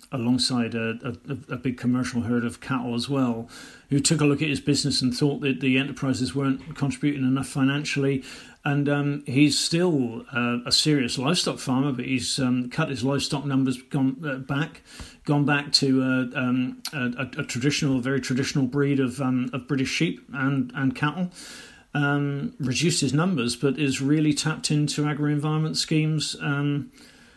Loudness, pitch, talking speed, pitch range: -24 LUFS, 135 Hz, 180 wpm, 130-145 Hz